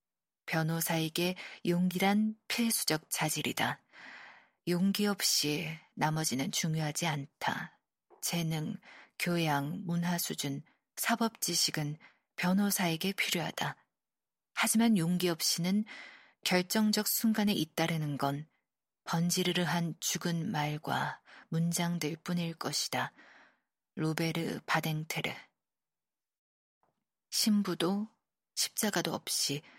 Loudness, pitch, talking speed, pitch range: -32 LUFS, 170 Hz, 205 characters per minute, 160-190 Hz